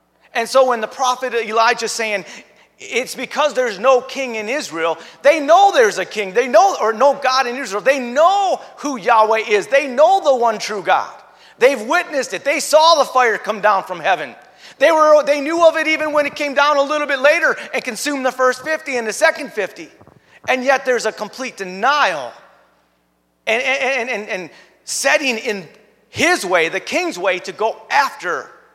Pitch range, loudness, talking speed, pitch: 225-300 Hz, -16 LUFS, 190 wpm, 265 Hz